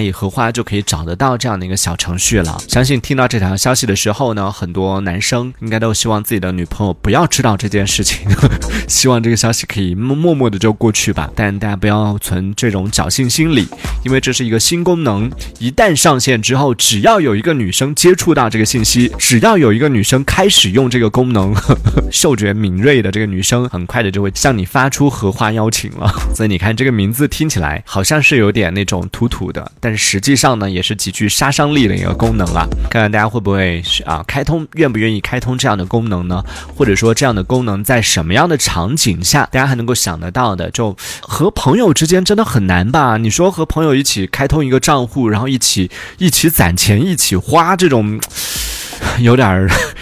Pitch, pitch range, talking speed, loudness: 110 Hz, 100-130 Hz, 330 characters per minute, -13 LUFS